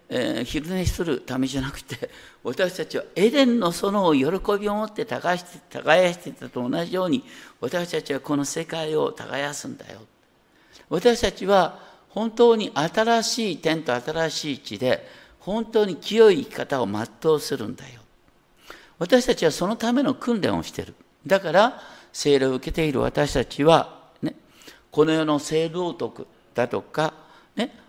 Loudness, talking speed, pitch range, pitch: -23 LUFS, 280 characters per minute, 145-220 Hz, 175 Hz